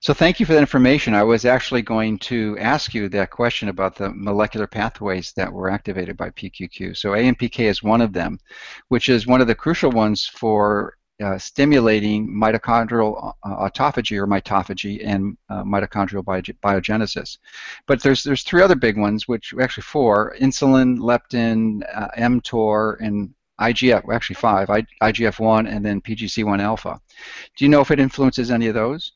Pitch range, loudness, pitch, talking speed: 105-125 Hz, -19 LUFS, 110 Hz, 165 wpm